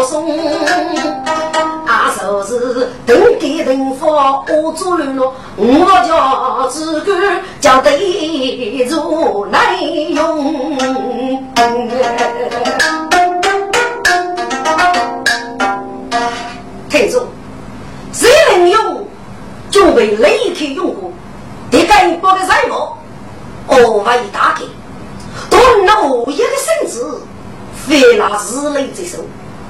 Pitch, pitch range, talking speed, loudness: 310 Hz, 255-360 Hz, 110 characters per minute, -12 LUFS